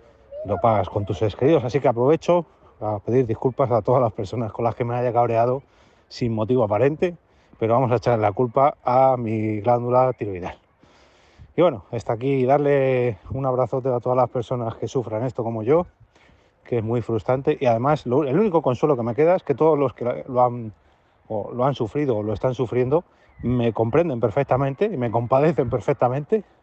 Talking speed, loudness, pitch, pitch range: 195 wpm, -22 LUFS, 125 Hz, 115-135 Hz